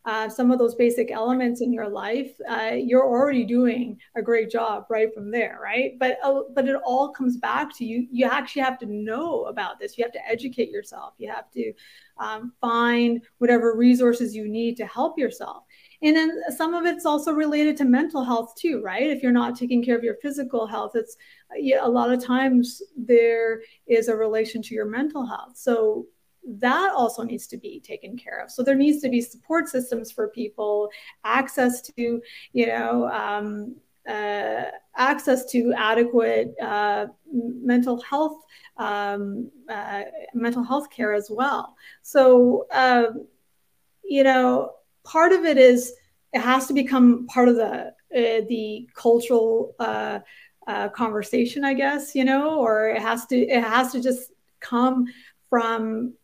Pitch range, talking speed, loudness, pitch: 230-270 Hz, 170 wpm, -22 LUFS, 245 Hz